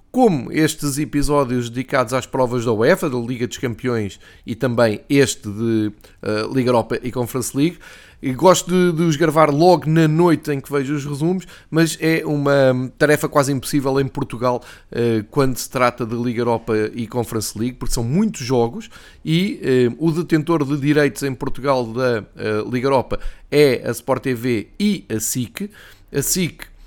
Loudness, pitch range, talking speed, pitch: -19 LUFS, 120-150 Hz, 165 wpm, 130 Hz